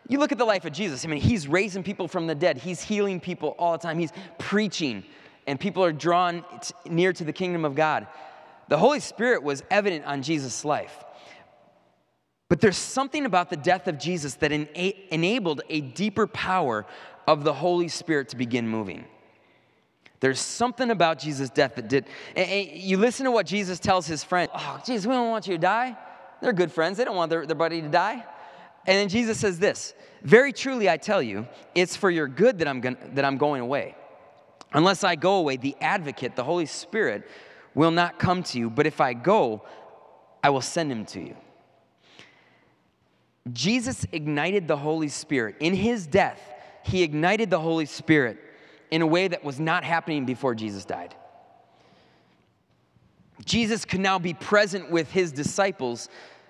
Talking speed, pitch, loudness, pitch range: 180 wpm, 175 Hz, -25 LUFS, 150-195 Hz